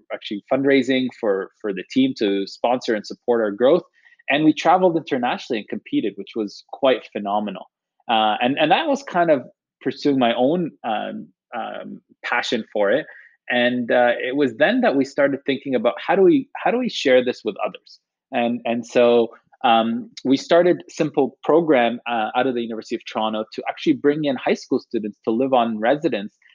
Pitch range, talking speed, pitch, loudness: 115-140 Hz, 190 wpm, 125 Hz, -20 LUFS